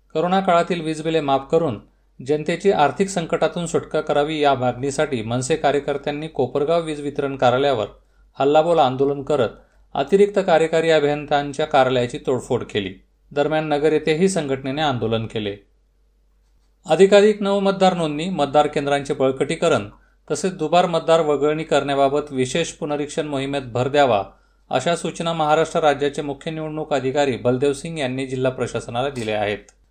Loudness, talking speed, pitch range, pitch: -20 LUFS, 130 wpm, 135-165 Hz, 150 Hz